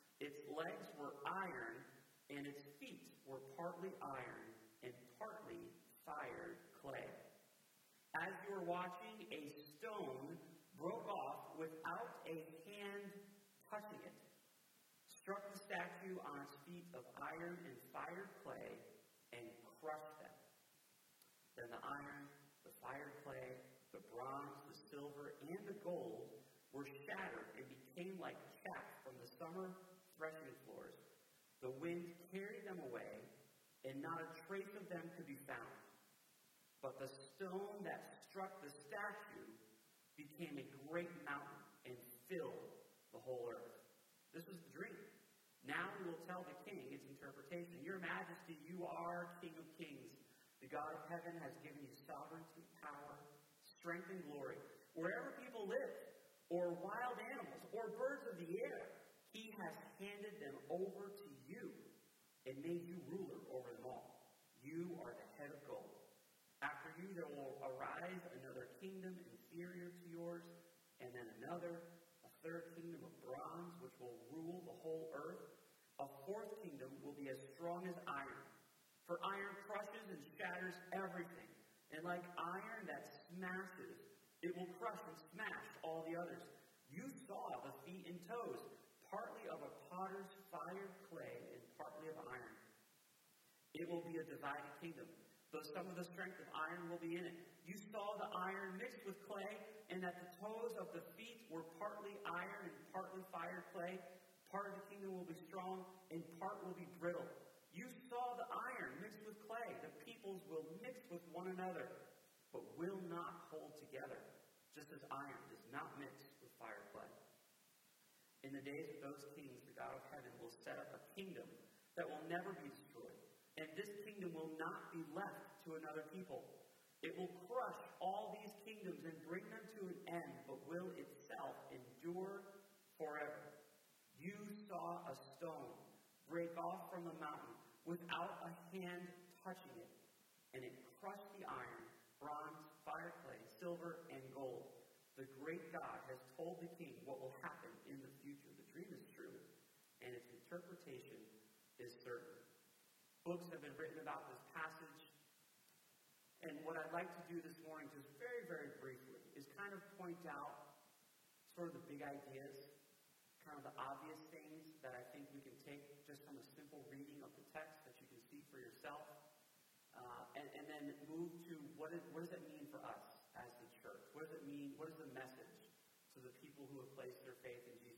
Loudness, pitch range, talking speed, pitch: -53 LUFS, 150-190 Hz, 160 wpm, 170 Hz